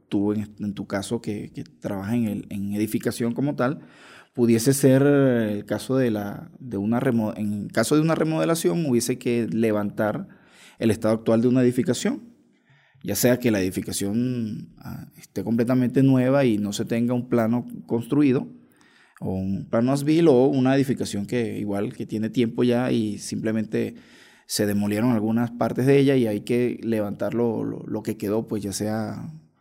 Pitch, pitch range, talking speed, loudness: 115 Hz, 105-125 Hz, 170 wpm, -23 LUFS